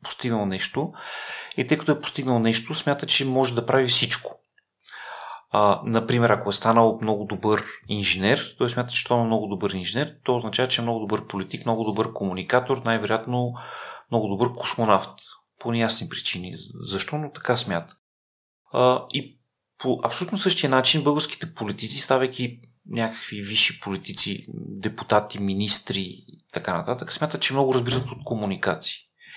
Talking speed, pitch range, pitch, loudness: 150 wpm, 105-130 Hz, 120 Hz, -24 LUFS